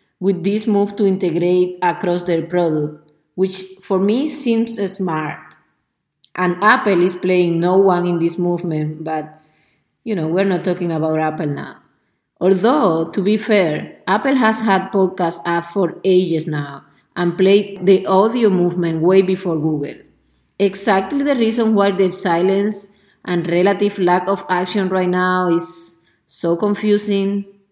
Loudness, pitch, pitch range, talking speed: -17 LUFS, 185 Hz, 170-200 Hz, 145 wpm